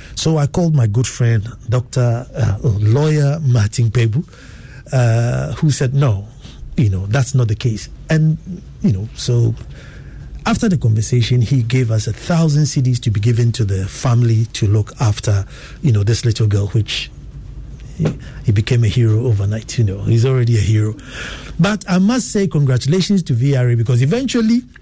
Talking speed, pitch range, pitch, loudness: 170 wpm, 110-140 Hz, 125 Hz, -16 LUFS